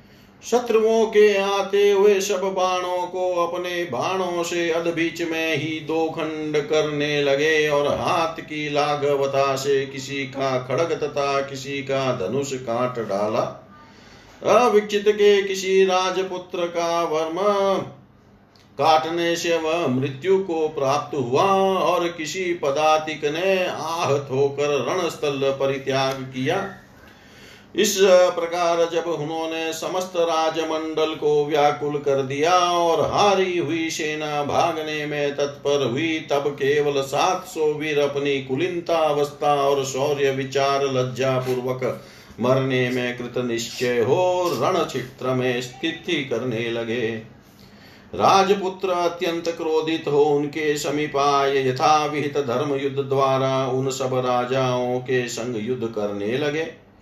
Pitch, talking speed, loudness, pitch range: 150 Hz, 115 wpm, -22 LUFS, 135-170 Hz